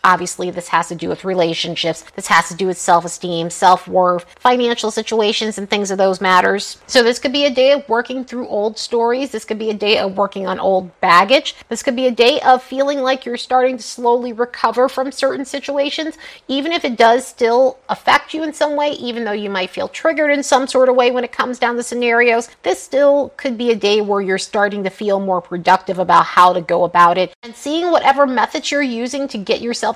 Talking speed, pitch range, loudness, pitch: 230 wpm, 190-265 Hz, -16 LUFS, 235 Hz